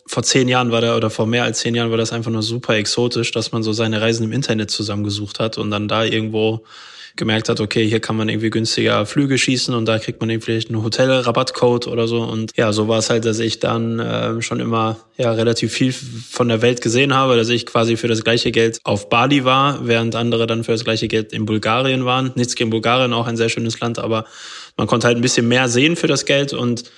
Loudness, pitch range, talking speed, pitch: -17 LUFS, 110-120 Hz, 245 wpm, 115 Hz